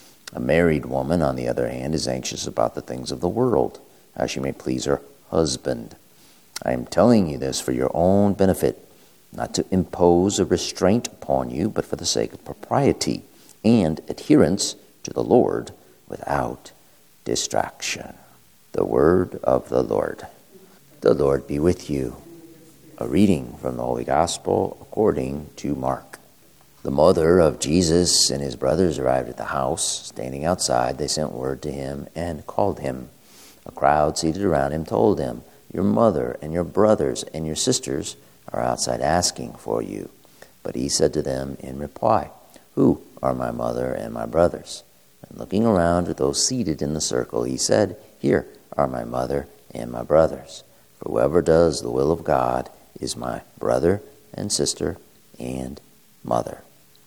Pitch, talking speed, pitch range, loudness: 70 Hz, 165 wpm, 65-85 Hz, -22 LUFS